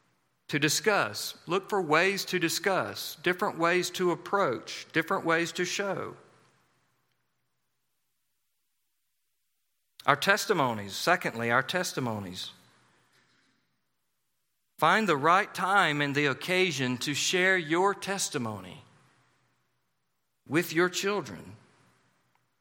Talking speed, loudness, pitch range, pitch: 90 wpm, -27 LUFS, 140-190 Hz, 170 Hz